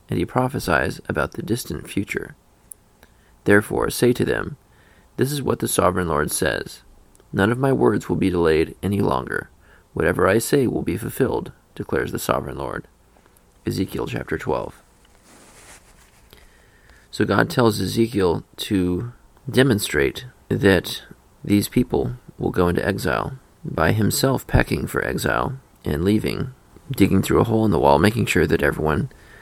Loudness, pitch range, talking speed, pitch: -21 LUFS, 95-125 Hz, 145 wpm, 105 Hz